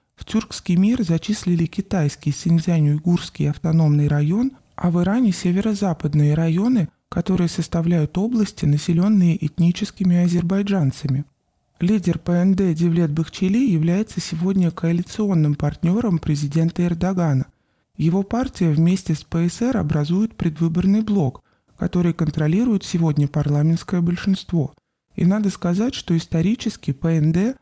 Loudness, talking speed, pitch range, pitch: -20 LUFS, 105 wpm, 160-195 Hz, 175 Hz